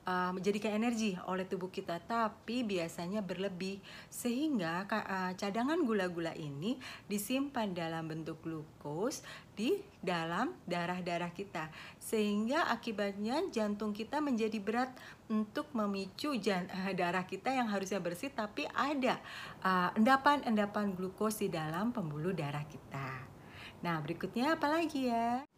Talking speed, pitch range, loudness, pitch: 110 wpm, 175-235 Hz, -36 LUFS, 205 Hz